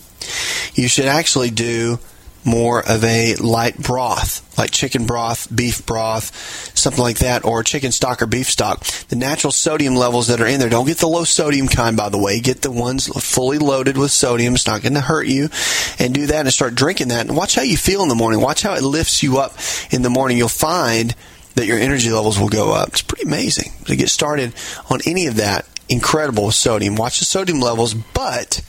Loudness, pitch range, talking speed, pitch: -16 LUFS, 115-135 Hz, 220 wpm, 120 Hz